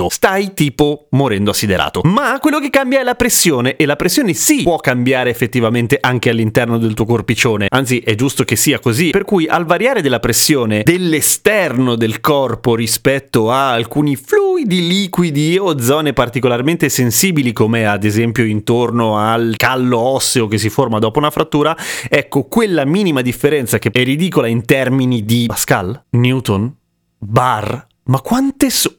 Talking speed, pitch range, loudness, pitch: 160 wpm, 115-160 Hz, -14 LUFS, 130 Hz